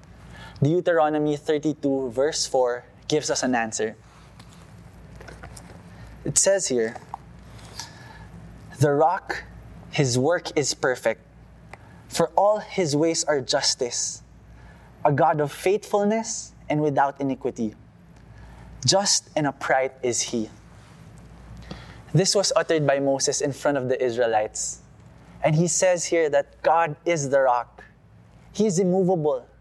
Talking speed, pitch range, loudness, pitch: 115 wpm, 125-170 Hz, -23 LUFS, 150 Hz